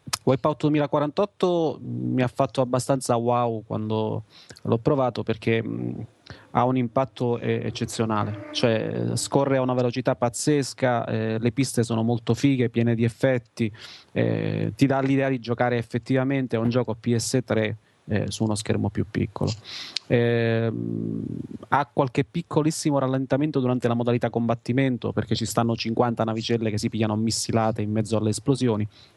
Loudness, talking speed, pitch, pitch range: -24 LUFS, 140 wpm, 120 Hz, 110-130 Hz